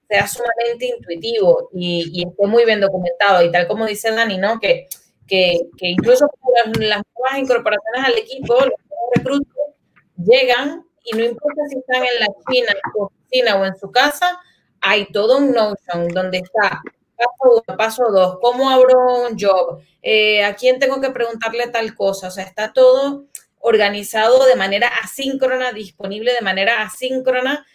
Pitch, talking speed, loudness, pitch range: 235 Hz, 165 wpm, -16 LUFS, 200-260 Hz